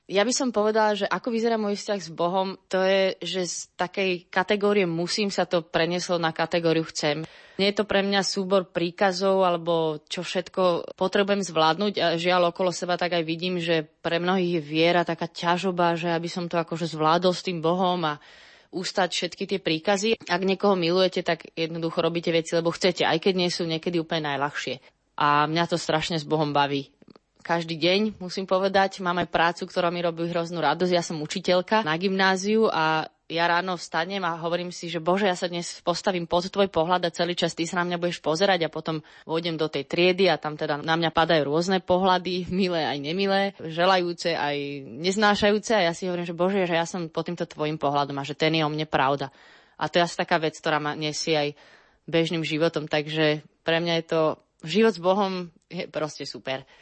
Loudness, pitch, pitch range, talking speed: -25 LUFS, 175 Hz, 160-185 Hz, 200 wpm